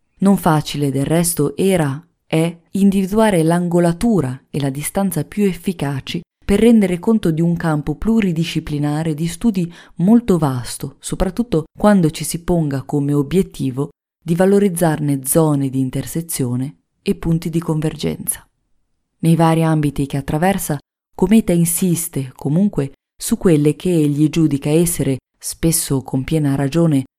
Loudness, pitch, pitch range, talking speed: -17 LUFS, 165 Hz, 145-185 Hz, 130 wpm